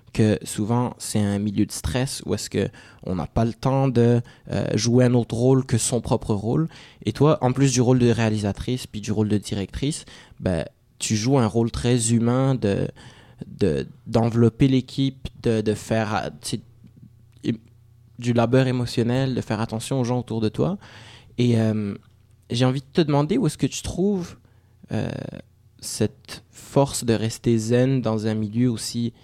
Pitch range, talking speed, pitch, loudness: 110-130 Hz, 180 wpm, 120 Hz, -23 LUFS